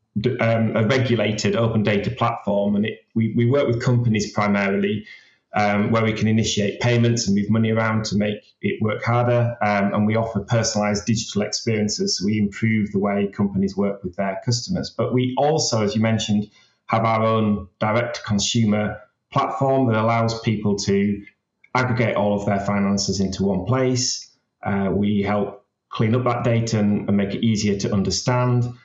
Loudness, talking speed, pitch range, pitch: -21 LUFS, 175 wpm, 100-115 Hz, 110 Hz